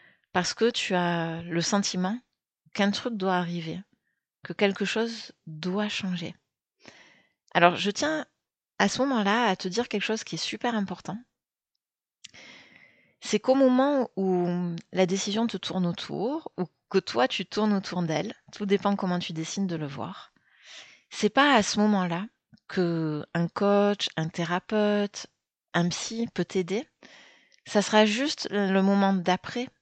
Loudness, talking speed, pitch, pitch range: -27 LUFS, 145 wpm, 200 Hz, 175-220 Hz